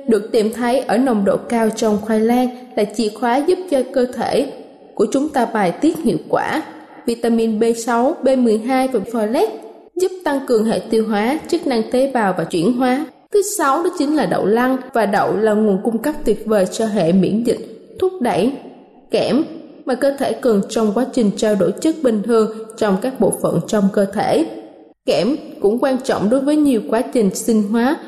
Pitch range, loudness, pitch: 220-270 Hz, -17 LUFS, 240 Hz